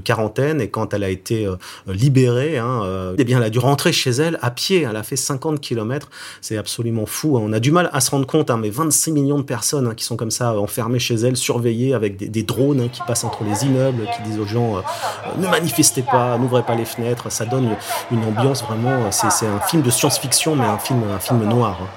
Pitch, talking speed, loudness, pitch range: 120 Hz, 255 wpm, -19 LUFS, 110-140 Hz